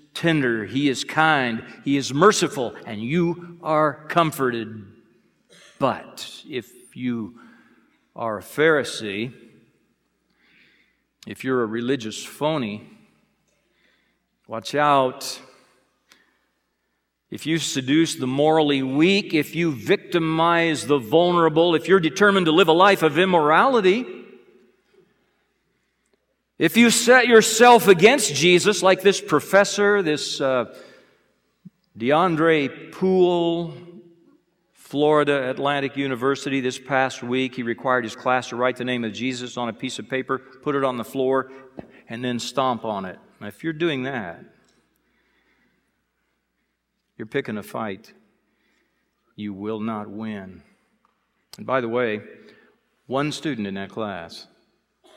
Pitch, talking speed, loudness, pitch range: 140 Hz, 120 wpm, -21 LUFS, 125-170 Hz